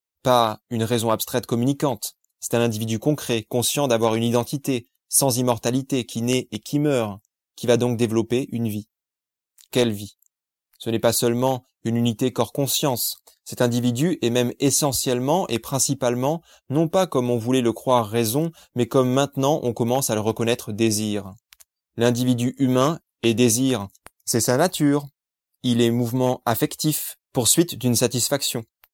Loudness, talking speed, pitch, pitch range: -22 LUFS, 150 wpm, 125 Hz, 115-135 Hz